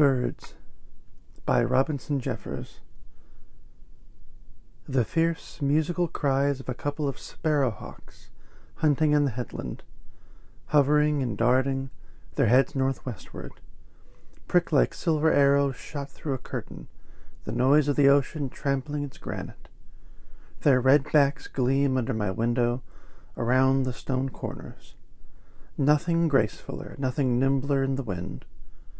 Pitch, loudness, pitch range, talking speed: 135 Hz, -26 LUFS, 120-145 Hz, 120 wpm